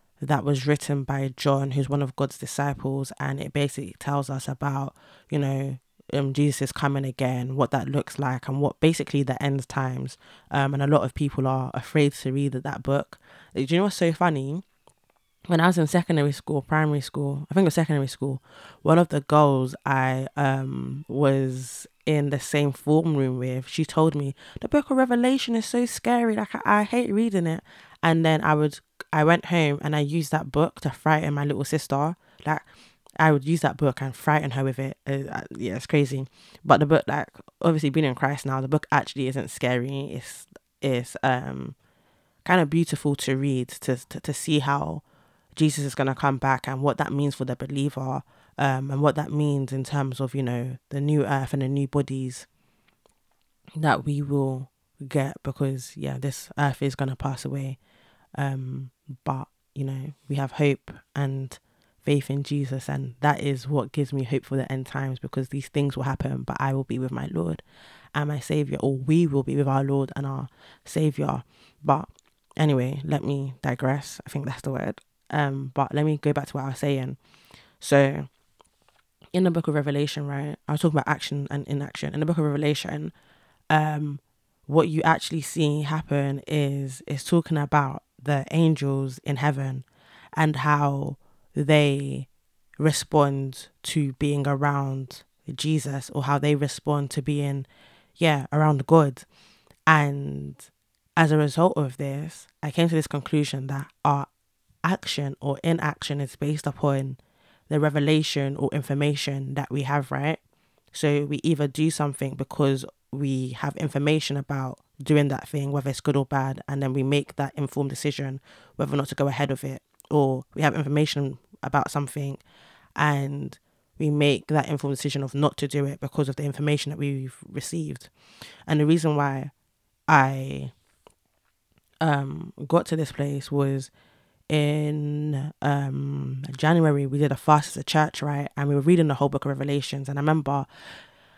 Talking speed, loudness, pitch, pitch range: 185 wpm, -25 LUFS, 140 Hz, 135-150 Hz